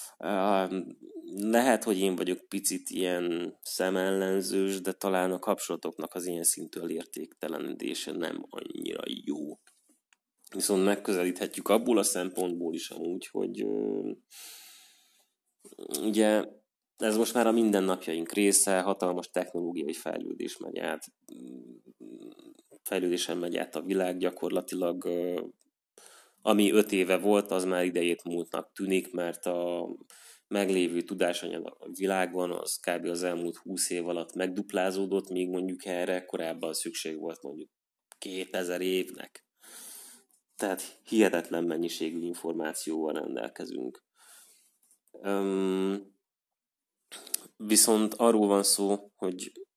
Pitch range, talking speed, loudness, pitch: 90-100 Hz, 110 wpm, -30 LUFS, 95 Hz